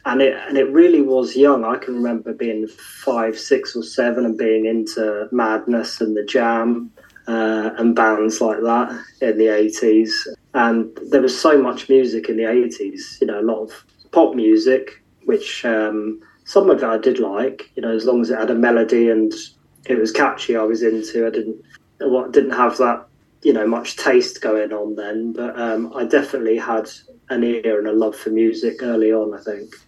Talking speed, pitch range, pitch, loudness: 200 wpm, 110-125 Hz, 115 Hz, -18 LUFS